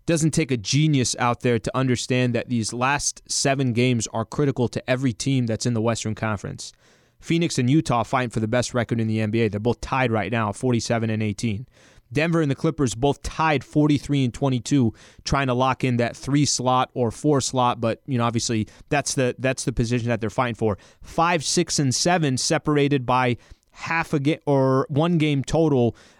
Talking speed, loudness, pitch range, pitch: 200 wpm, -22 LUFS, 115-145 Hz, 125 Hz